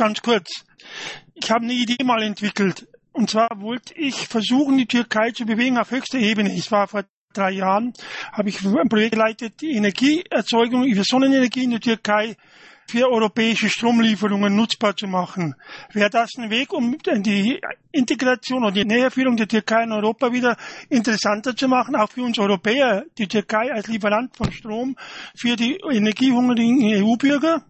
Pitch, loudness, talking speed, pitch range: 230 Hz, -20 LUFS, 160 wpm, 210-255 Hz